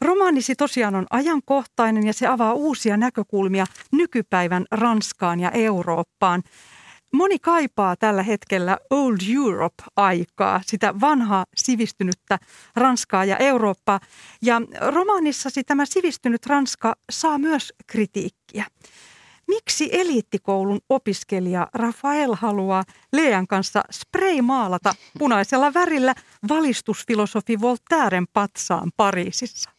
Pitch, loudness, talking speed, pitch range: 230 Hz, -21 LUFS, 95 wpm, 195-275 Hz